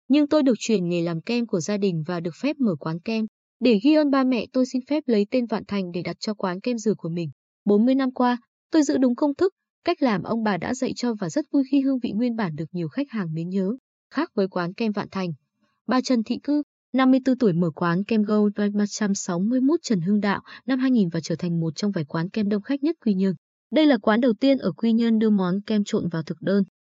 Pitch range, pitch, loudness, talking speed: 190-260 Hz, 215 Hz, -23 LUFS, 255 wpm